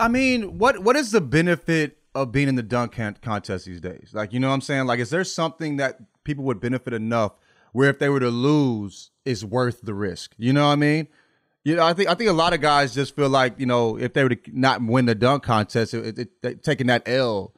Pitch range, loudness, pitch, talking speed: 115-150 Hz, -22 LUFS, 130 Hz, 255 wpm